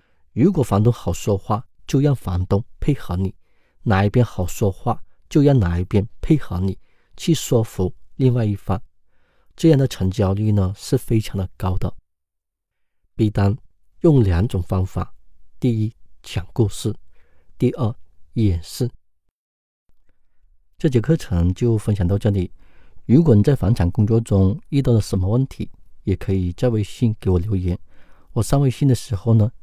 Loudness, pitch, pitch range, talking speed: -20 LUFS, 100 Hz, 90-120 Hz, 220 characters per minute